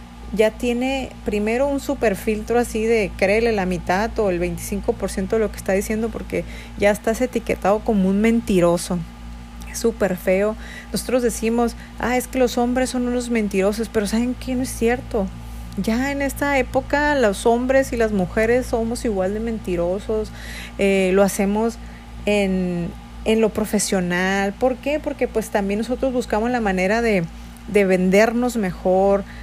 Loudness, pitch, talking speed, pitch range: -20 LUFS, 220 Hz, 160 wpm, 195-240 Hz